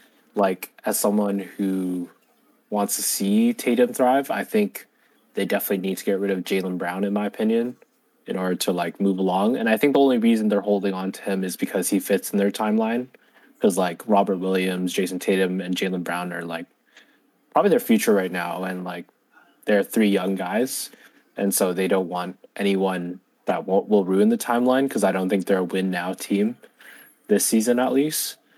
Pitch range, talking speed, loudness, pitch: 95-110 Hz, 195 wpm, -23 LUFS, 100 Hz